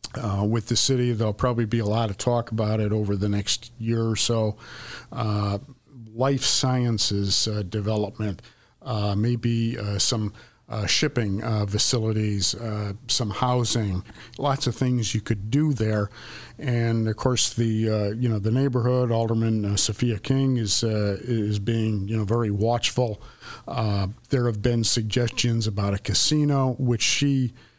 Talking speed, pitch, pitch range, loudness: 160 wpm, 115 Hz, 105-120 Hz, -24 LUFS